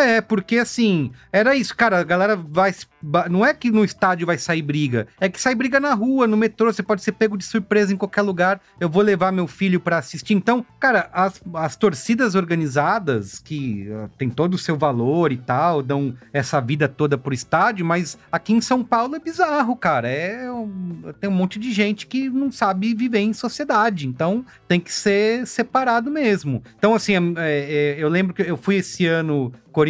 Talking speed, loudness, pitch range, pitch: 200 wpm, -20 LUFS, 160-225 Hz, 190 Hz